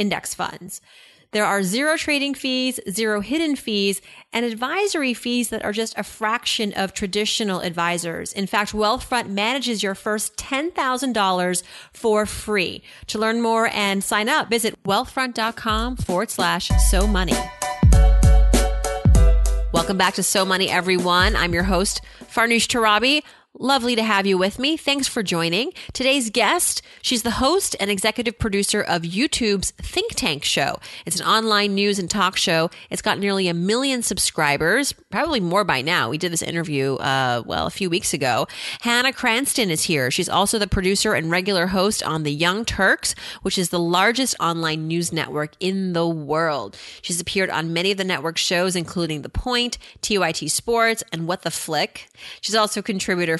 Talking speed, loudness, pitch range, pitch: 165 wpm, -21 LUFS, 180-230 Hz, 205 Hz